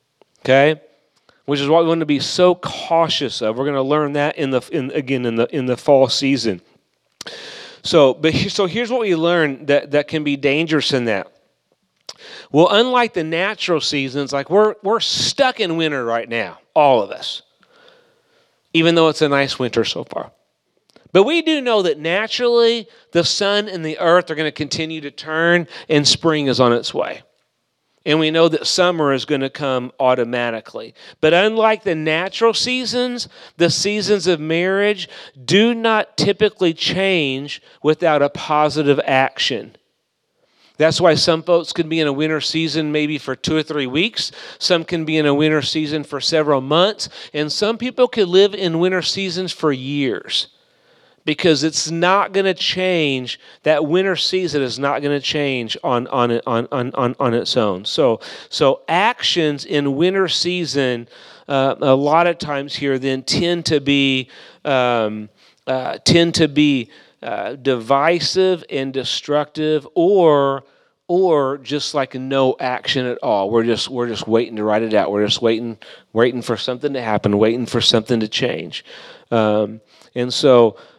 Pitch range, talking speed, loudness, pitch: 135-175 Hz, 170 wpm, -17 LUFS, 150 Hz